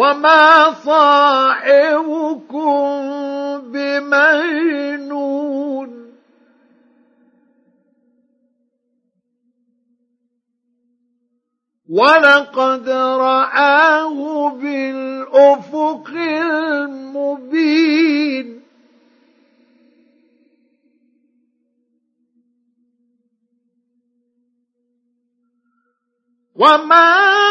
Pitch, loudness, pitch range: 270 Hz, -14 LUFS, 245-285 Hz